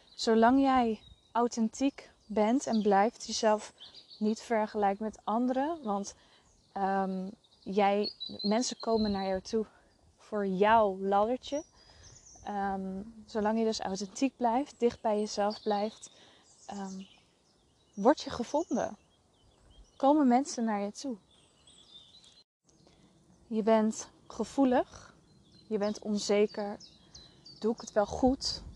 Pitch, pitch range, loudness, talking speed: 220 Hz, 205-240 Hz, -31 LUFS, 110 wpm